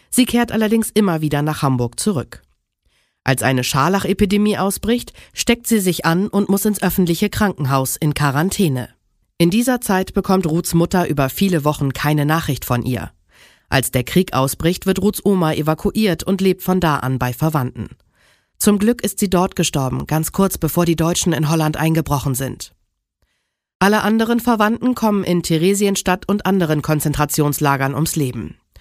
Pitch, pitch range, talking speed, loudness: 170 Hz, 145-200 Hz, 160 wpm, -17 LUFS